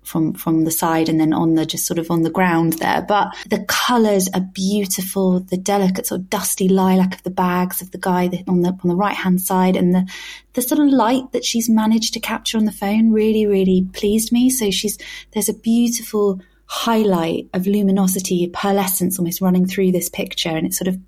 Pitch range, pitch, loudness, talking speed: 180-210 Hz, 190 Hz, -18 LUFS, 215 wpm